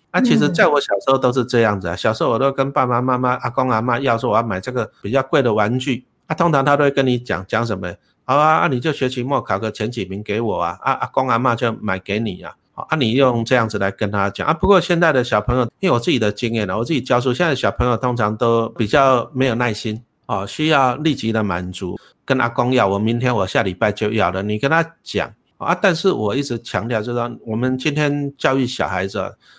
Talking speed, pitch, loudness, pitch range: 350 characters per minute, 120 Hz, -18 LUFS, 110-135 Hz